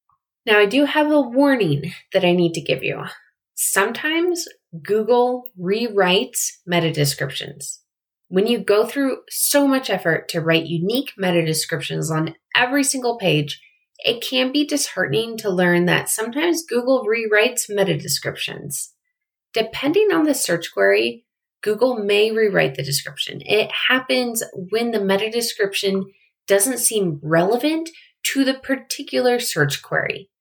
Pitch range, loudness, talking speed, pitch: 170-265 Hz, -19 LUFS, 135 wpm, 210 Hz